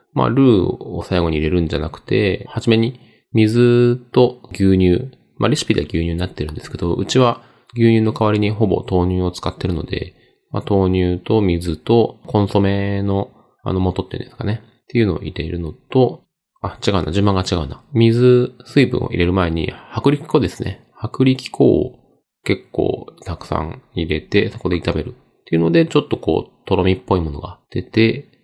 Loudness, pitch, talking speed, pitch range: -18 LUFS, 105 Hz, 350 characters per minute, 90-120 Hz